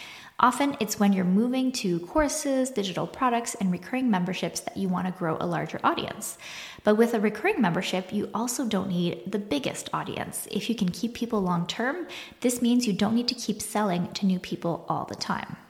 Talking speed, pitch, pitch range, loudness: 205 wpm, 210 Hz, 185-240 Hz, -27 LUFS